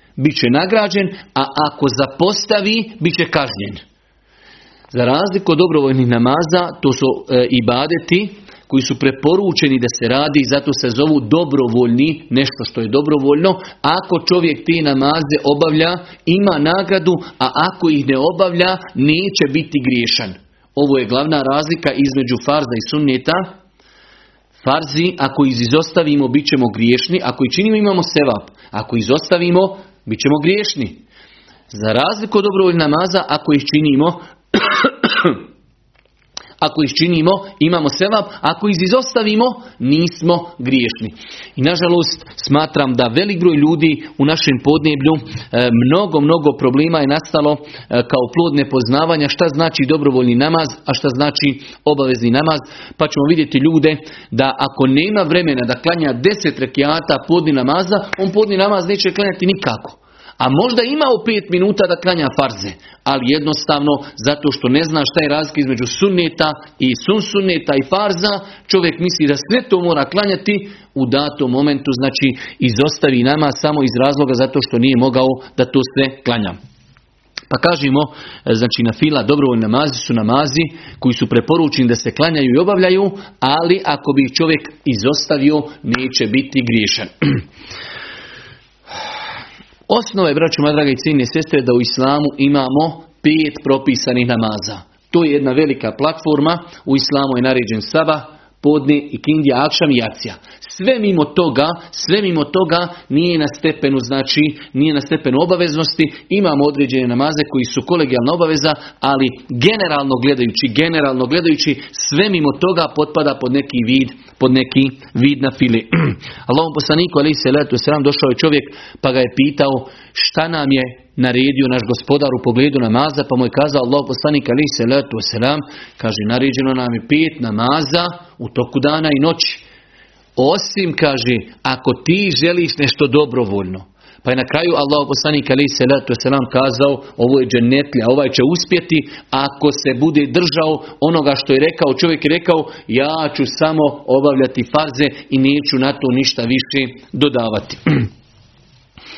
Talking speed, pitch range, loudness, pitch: 145 wpm, 130-165 Hz, -15 LUFS, 145 Hz